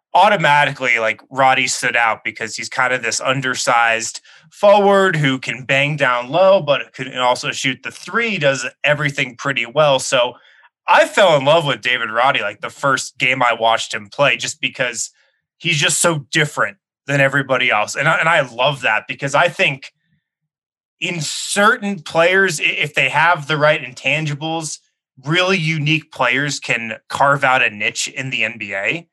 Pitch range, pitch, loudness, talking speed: 130-160 Hz, 140 Hz, -16 LUFS, 165 wpm